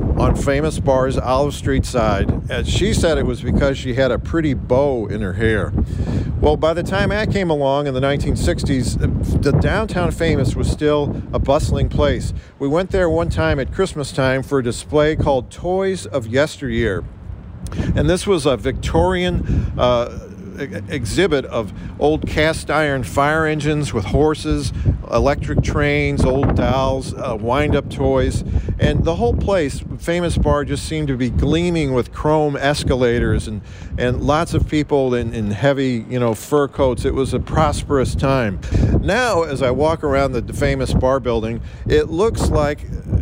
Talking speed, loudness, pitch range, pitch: 160 wpm, -18 LUFS, 115-150 Hz, 135 Hz